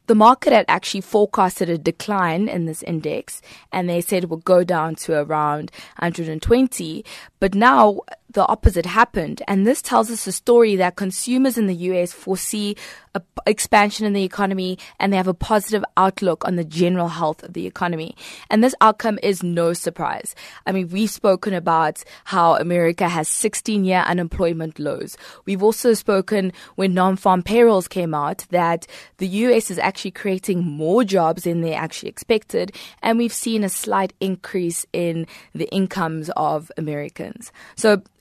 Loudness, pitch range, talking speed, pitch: -19 LUFS, 170-210 Hz, 170 wpm, 190 Hz